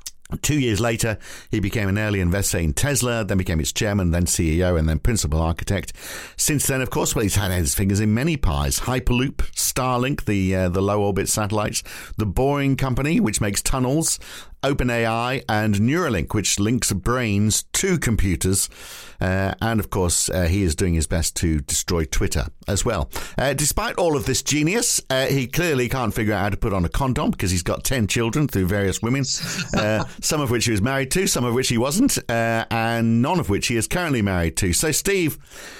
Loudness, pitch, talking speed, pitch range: -21 LUFS, 110 Hz, 200 wpm, 95-130 Hz